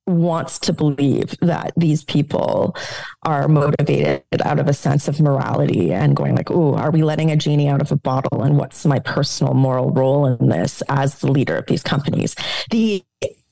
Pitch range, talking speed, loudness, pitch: 135-155 Hz, 185 wpm, -18 LUFS, 145 Hz